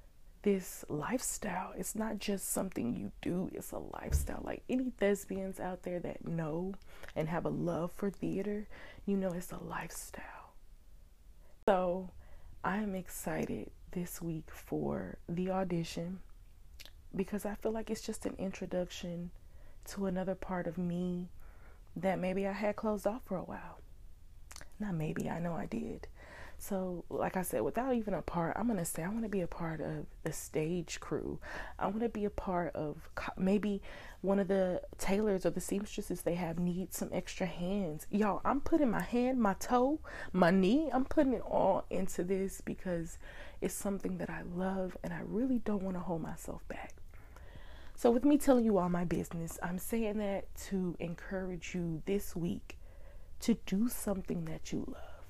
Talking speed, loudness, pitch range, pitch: 175 wpm, -36 LUFS, 170-205 Hz, 185 Hz